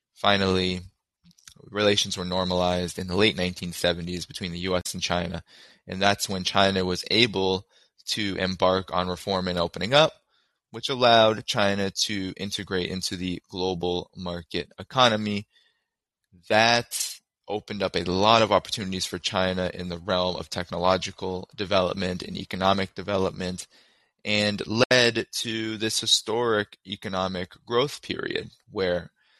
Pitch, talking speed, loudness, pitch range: 95 Hz, 130 wpm, -25 LUFS, 90-105 Hz